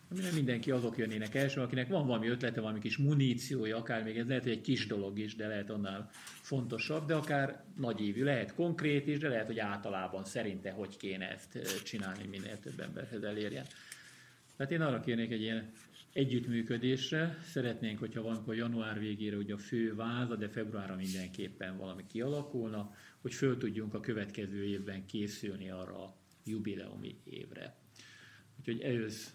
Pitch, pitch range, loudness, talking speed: 115 Hz, 105-130 Hz, -37 LUFS, 160 wpm